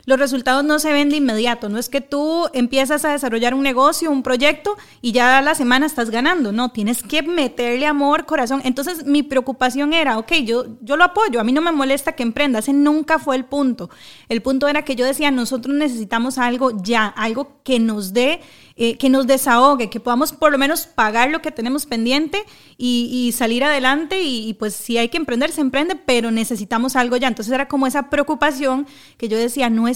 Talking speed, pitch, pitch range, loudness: 215 wpm, 265 Hz, 240-295 Hz, -18 LUFS